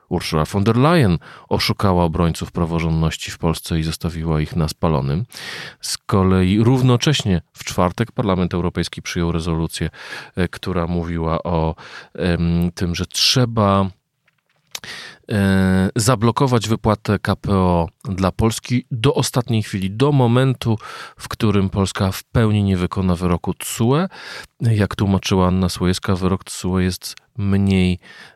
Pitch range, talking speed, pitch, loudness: 90-115 Hz, 120 wpm, 95 Hz, -19 LUFS